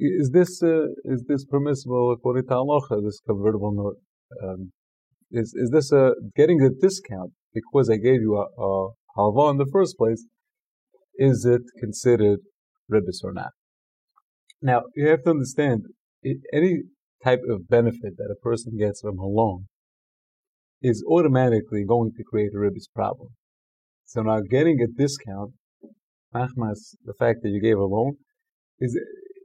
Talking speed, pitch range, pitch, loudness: 155 wpm, 105-145 Hz, 120 Hz, -23 LUFS